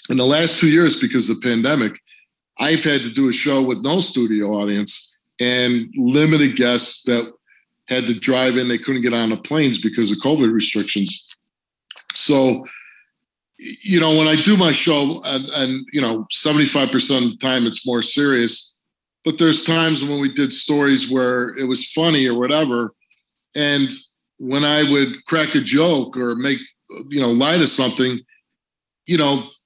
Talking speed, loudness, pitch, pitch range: 170 wpm, -17 LUFS, 135 Hz, 120-150 Hz